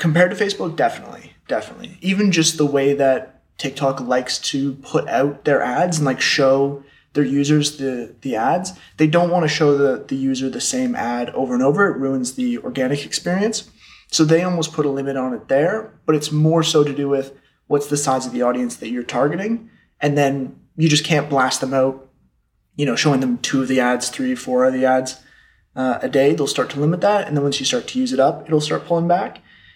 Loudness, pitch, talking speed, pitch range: -19 LUFS, 145 Hz, 225 wpm, 135-170 Hz